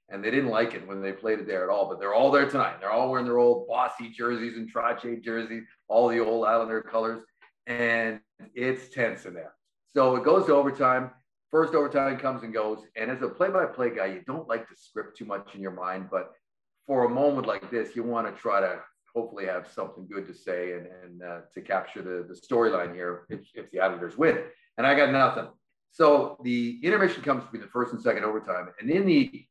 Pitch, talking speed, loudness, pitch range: 115 Hz, 225 wpm, -27 LUFS, 100-130 Hz